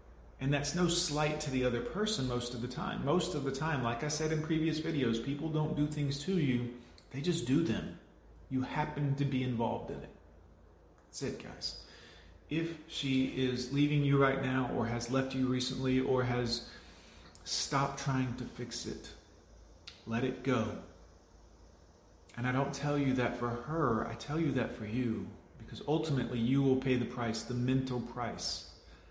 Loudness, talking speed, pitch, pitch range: -34 LUFS, 180 wpm, 125 Hz, 115-140 Hz